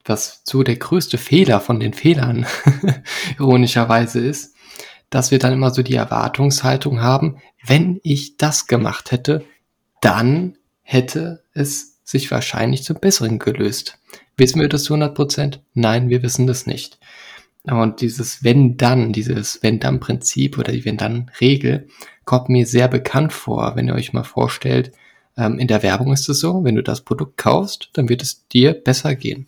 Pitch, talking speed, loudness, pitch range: 130 Hz, 165 wpm, -17 LUFS, 120-145 Hz